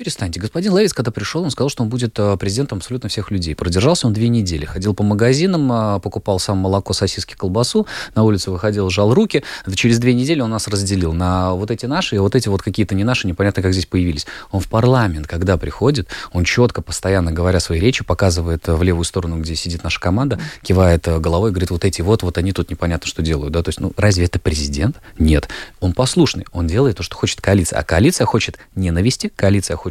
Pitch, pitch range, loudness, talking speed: 100 Hz, 90-115 Hz, -17 LUFS, 210 wpm